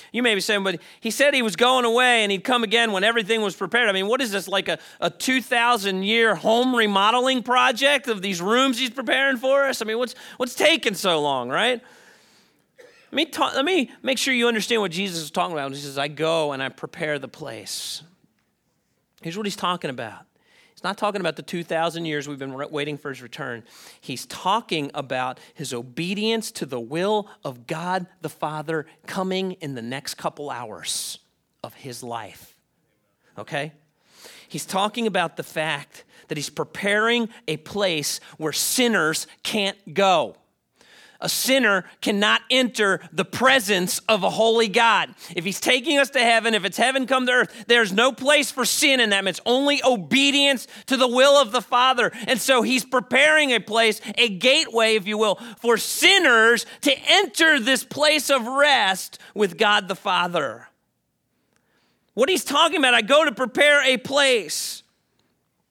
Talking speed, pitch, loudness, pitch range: 180 wpm, 220 Hz, -20 LUFS, 170-255 Hz